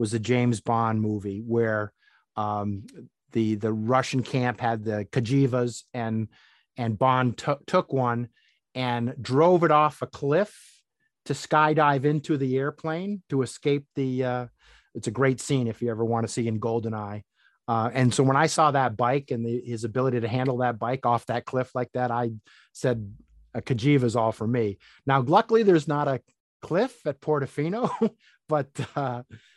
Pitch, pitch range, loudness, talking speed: 125 Hz, 115-140 Hz, -26 LUFS, 175 wpm